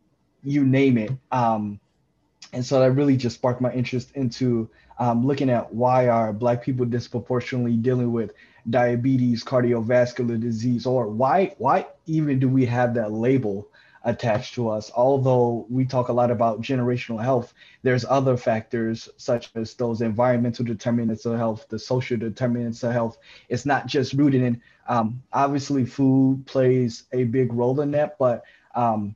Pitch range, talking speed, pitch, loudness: 115-130 Hz, 160 wpm, 125 Hz, -23 LUFS